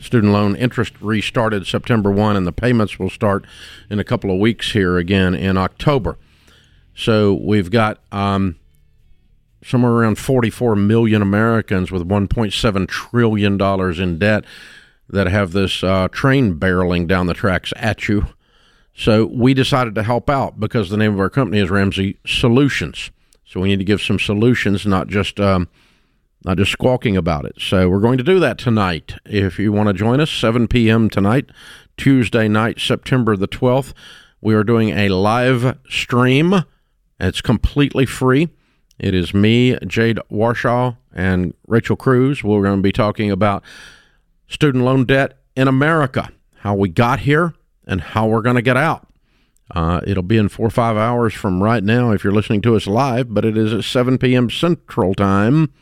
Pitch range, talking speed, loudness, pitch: 100-125 Hz, 170 wpm, -16 LUFS, 110 Hz